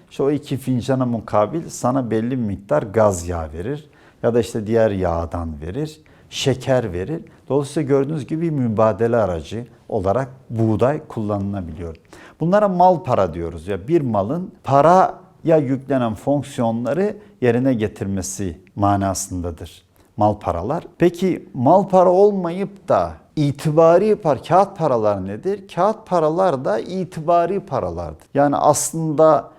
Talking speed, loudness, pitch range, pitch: 125 wpm, -19 LUFS, 105-160 Hz, 130 Hz